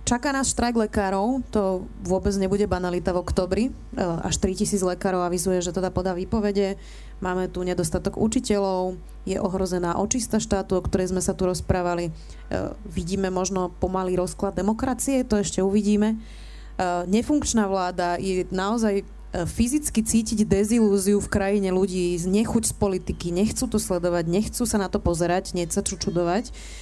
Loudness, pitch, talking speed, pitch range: -24 LUFS, 195 Hz, 150 wpm, 185-210 Hz